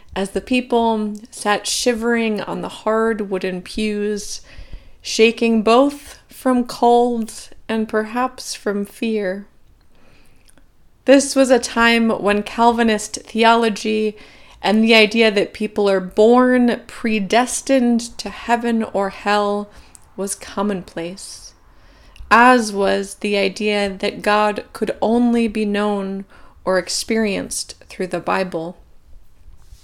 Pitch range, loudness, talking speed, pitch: 200-235 Hz, -18 LUFS, 110 wpm, 215 Hz